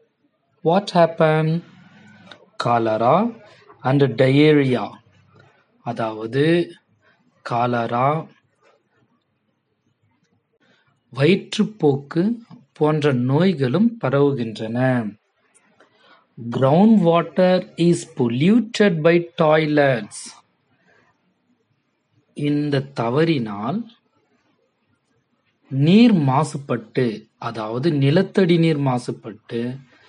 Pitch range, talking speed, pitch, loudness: 125-175 Hz, 40 wpm, 150 Hz, -19 LUFS